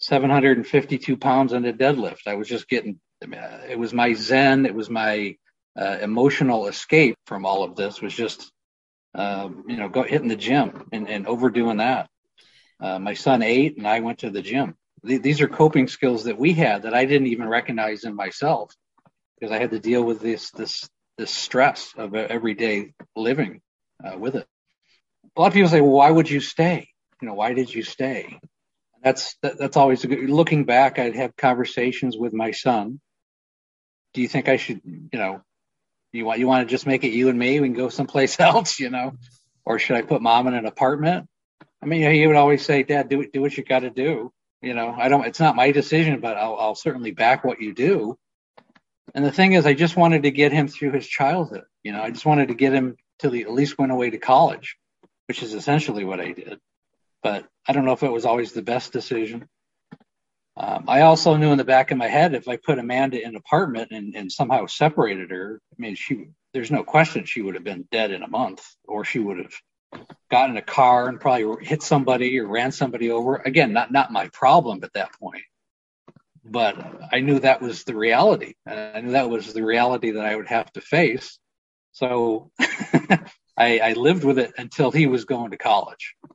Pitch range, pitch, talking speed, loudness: 115-140 Hz, 130 Hz, 215 wpm, -21 LUFS